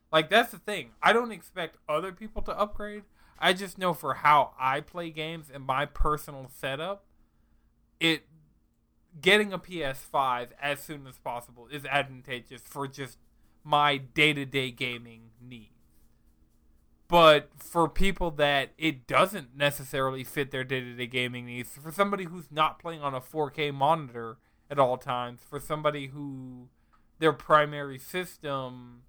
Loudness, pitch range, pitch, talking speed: -28 LUFS, 130-160 Hz, 145 Hz, 140 wpm